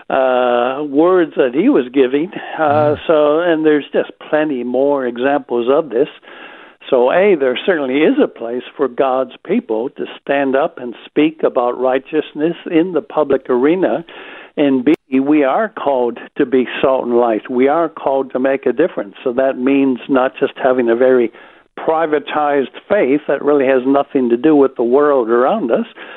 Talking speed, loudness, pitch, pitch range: 170 wpm, -15 LUFS, 135 Hz, 125-150 Hz